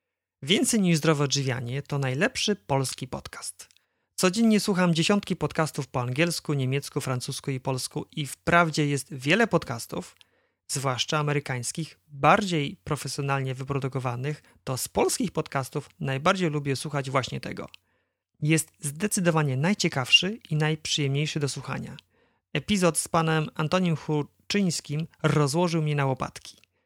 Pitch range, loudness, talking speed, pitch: 135-170 Hz, -26 LUFS, 120 wpm, 150 Hz